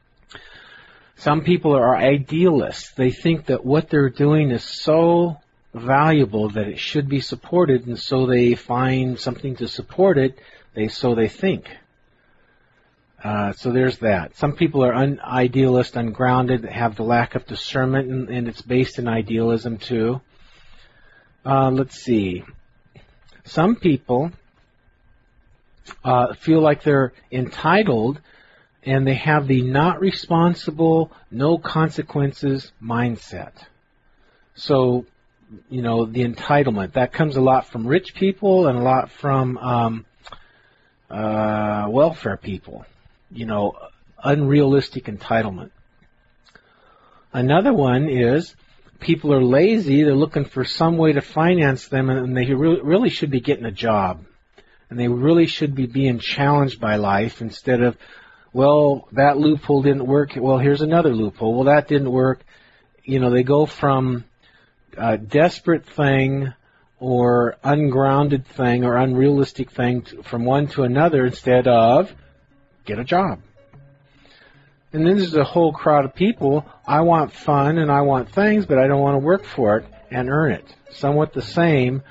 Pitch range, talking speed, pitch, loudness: 120-145 Hz, 140 wpm, 135 Hz, -19 LUFS